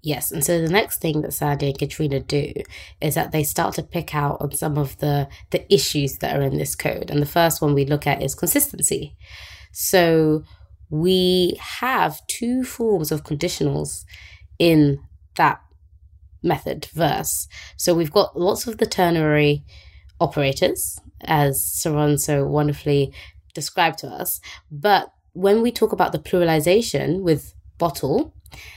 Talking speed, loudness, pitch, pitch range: 150 wpm, -21 LUFS, 150 Hz, 135-170 Hz